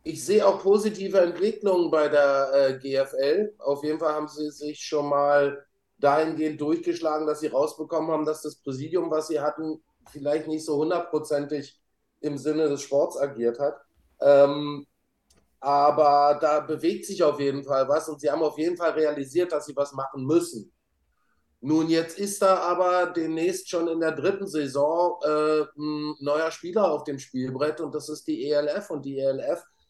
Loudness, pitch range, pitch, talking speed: -25 LUFS, 145-165 Hz, 150 Hz, 175 wpm